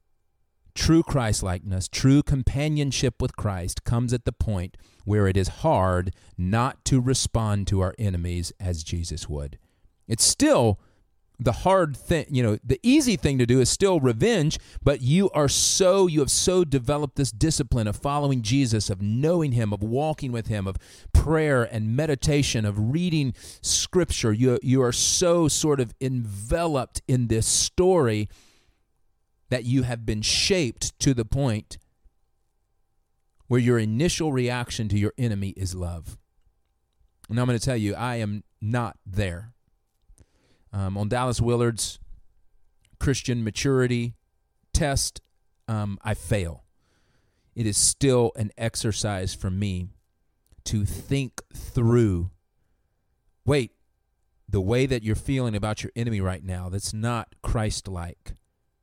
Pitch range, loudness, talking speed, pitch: 95-130 Hz, -24 LUFS, 140 wpm, 115 Hz